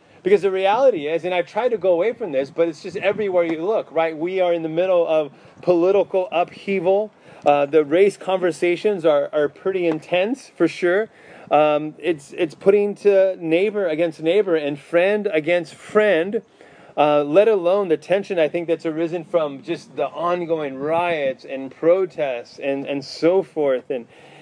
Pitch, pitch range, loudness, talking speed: 175 Hz, 155-195 Hz, -20 LUFS, 170 wpm